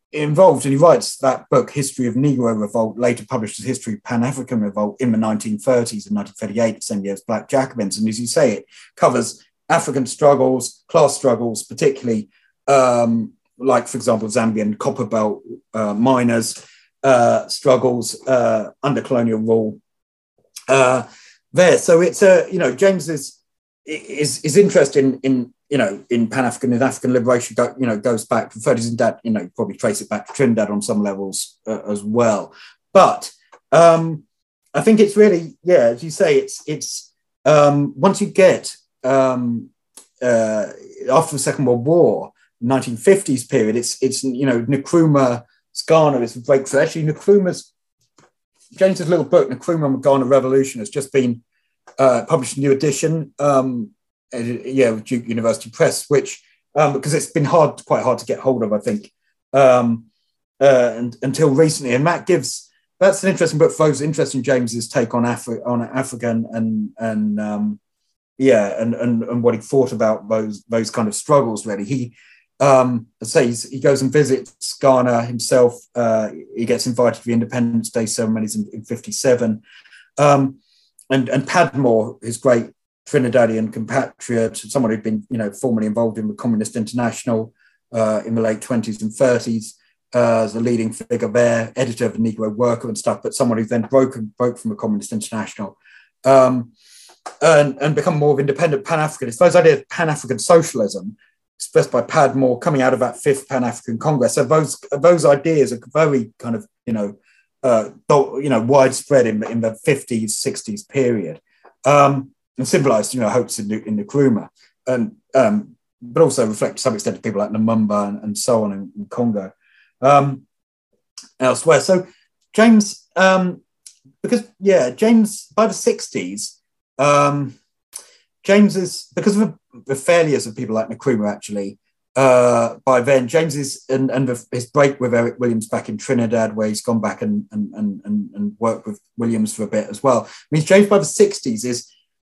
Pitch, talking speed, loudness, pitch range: 125 Hz, 175 wpm, -17 LUFS, 115-150 Hz